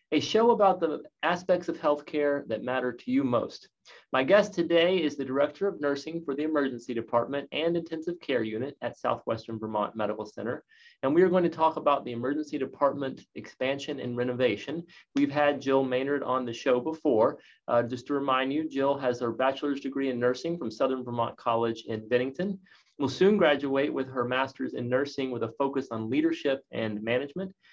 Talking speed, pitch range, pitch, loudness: 190 wpm, 125-160 Hz, 140 Hz, -28 LUFS